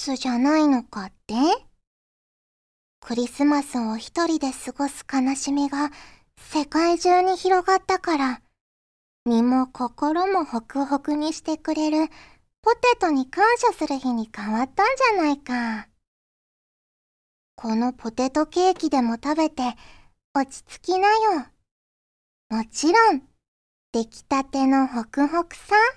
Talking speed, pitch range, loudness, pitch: 235 characters per minute, 255-345 Hz, -23 LUFS, 285 Hz